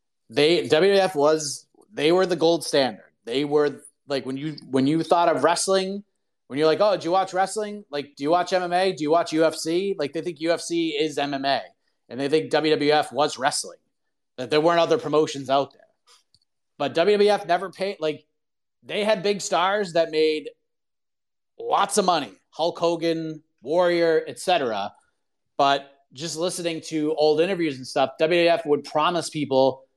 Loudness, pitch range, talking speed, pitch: -23 LUFS, 145-180 Hz, 170 wpm, 160 Hz